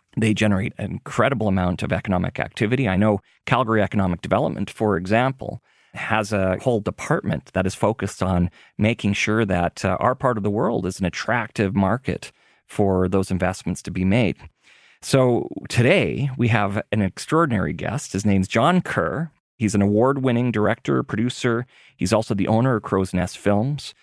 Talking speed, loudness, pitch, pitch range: 165 wpm, -22 LUFS, 105 Hz, 95-120 Hz